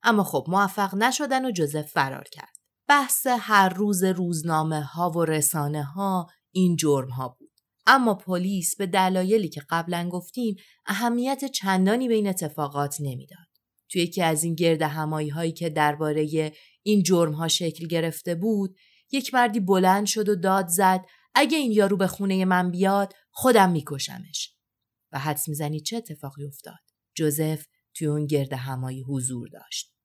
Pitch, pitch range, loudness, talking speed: 175 Hz, 155-200 Hz, -24 LUFS, 155 wpm